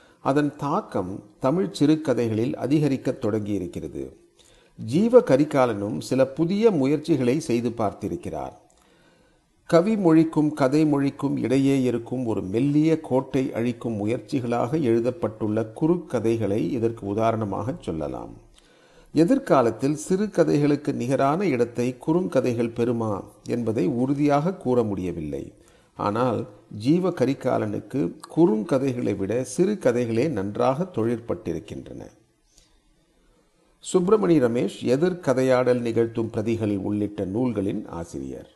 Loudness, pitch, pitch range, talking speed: -23 LUFS, 130 Hz, 115-155 Hz, 90 wpm